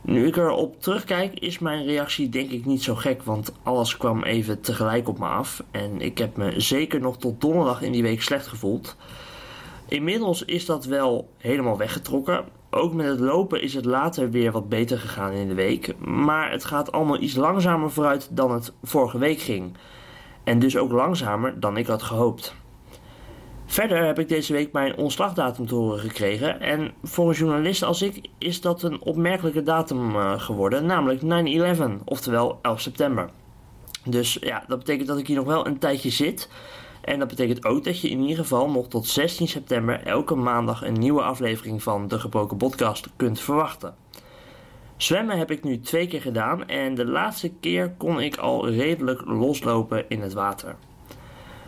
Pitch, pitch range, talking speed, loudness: 130 Hz, 115-155 Hz, 180 wpm, -24 LUFS